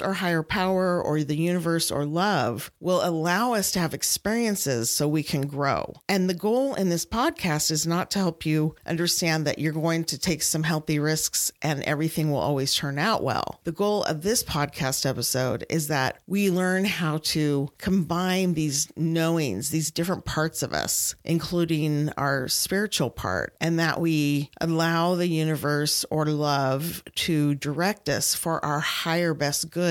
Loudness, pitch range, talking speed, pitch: -25 LUFS, 150-175 Hz, 170 wpm, 160 Hz